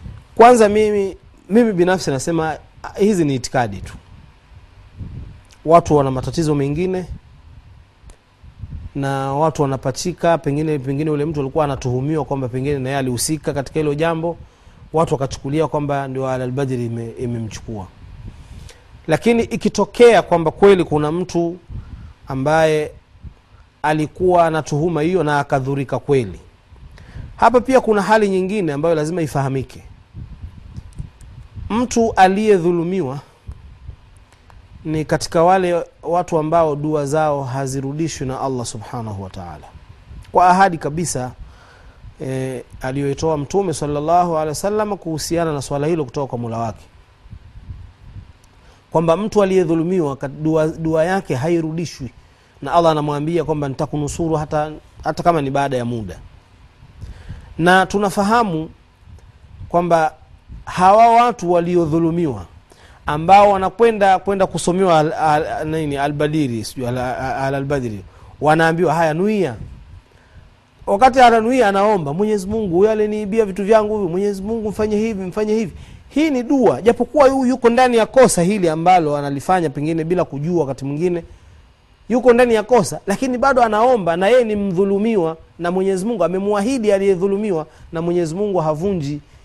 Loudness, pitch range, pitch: -17 LUFS, 125-185 Hz, 155 Hz